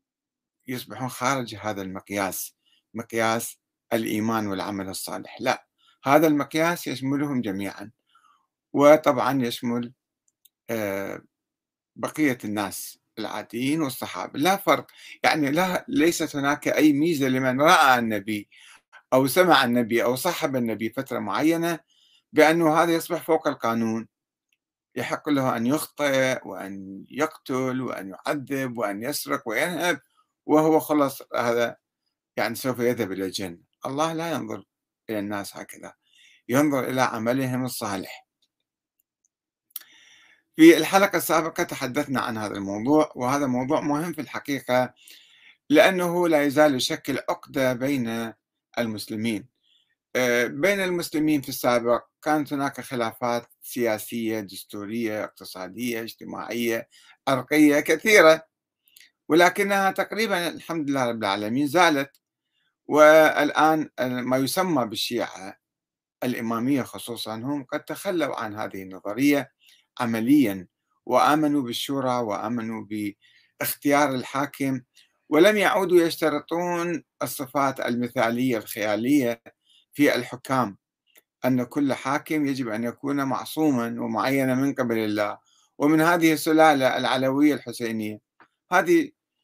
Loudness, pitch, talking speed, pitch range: -23 LUFS, 130 Hz, 105 wpm, 115-150 Hz